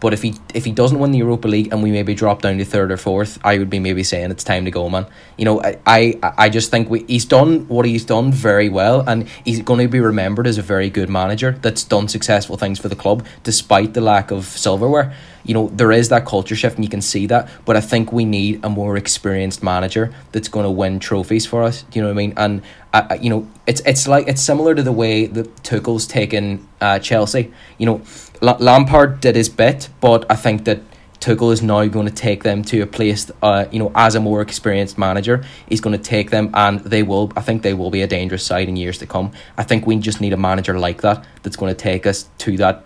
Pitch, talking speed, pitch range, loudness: 110 Hz, 255 wpm, 100-115 Hz, -16 LUFS